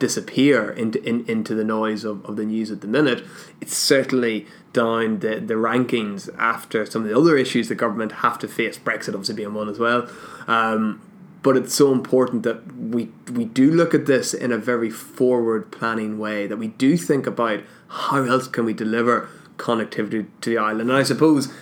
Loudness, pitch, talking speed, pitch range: -21 LUFS, 115 Hz, 195 wpm, 110-130 Hz